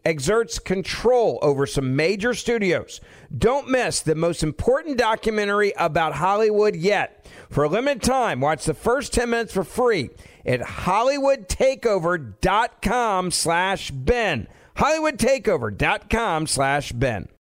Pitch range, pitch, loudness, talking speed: 160-240 Hz, 200 Hz, -21 LUFS, 105 wpm